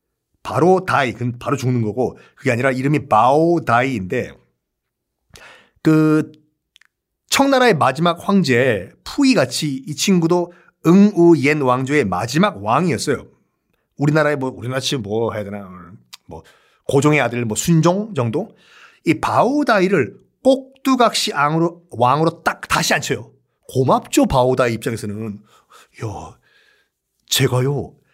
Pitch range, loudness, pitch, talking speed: 125-175 Hz, -17 LUFS, 150 Hz, 250 characters per minute